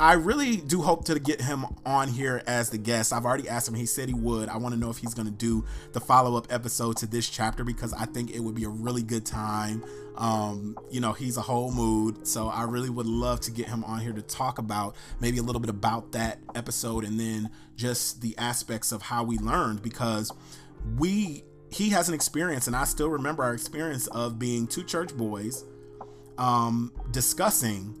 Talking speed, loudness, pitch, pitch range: 215 wpm, -28 LUFS, 120 Hz, 110-125 Hz